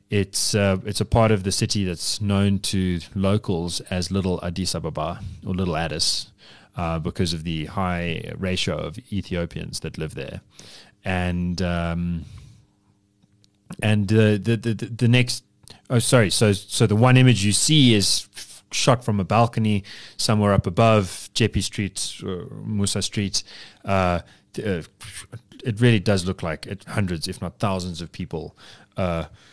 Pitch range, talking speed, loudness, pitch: 90-110 Hz, 150 wpm, -22 LUFS, 100 Hz